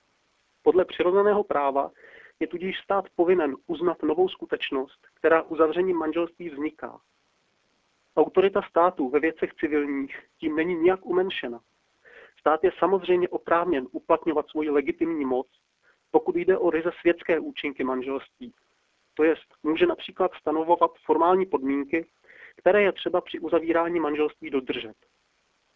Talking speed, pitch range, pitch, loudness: 120 wpm, 155-185 Hz, 170 Hz, -25 LUFS